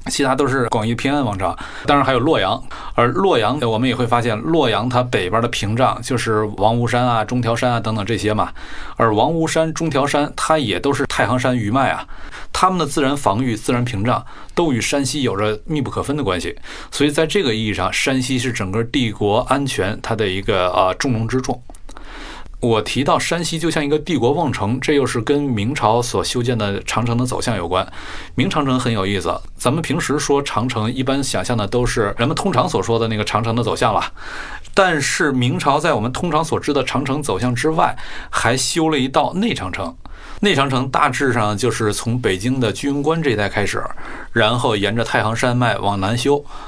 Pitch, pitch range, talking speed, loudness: 125 Hz, 115-140 Hz, 305 characters per minute, -18 LUFS